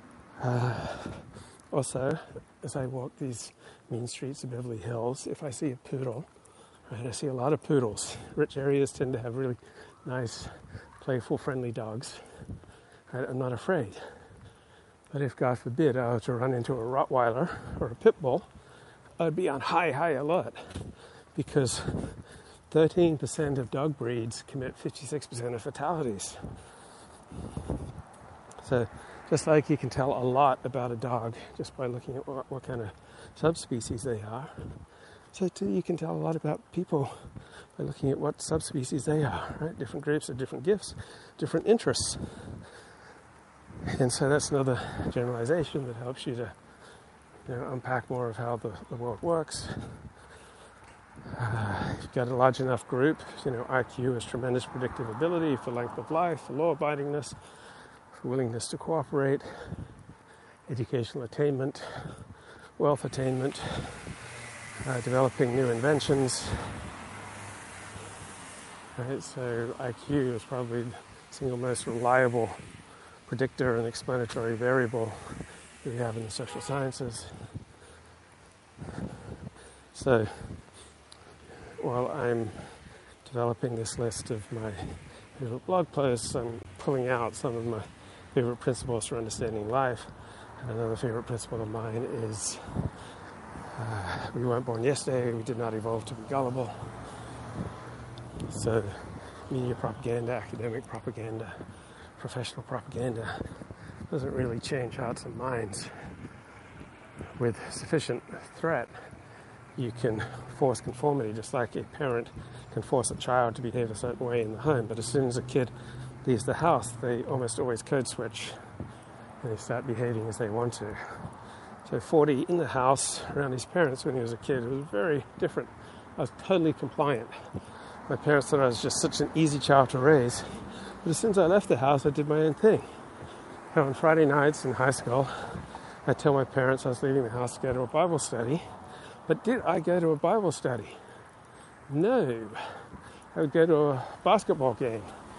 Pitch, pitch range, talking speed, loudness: 125 Hz, 115-140 Hz, 150 wpm, -30 LUFS